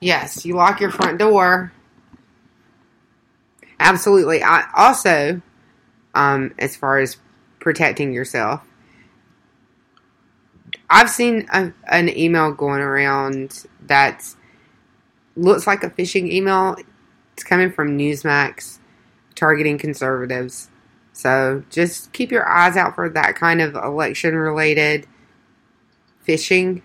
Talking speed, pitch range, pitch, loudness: 105 wpm, 130-180 Hz, 150 Hz, -17 LUFS